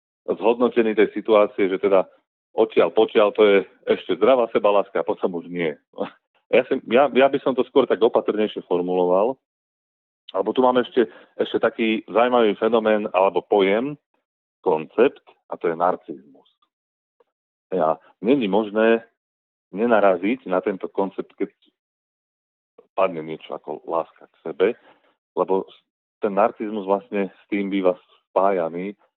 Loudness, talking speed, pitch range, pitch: -21 LUFS, 135 wpm, 95-120 Hz, 105 Hz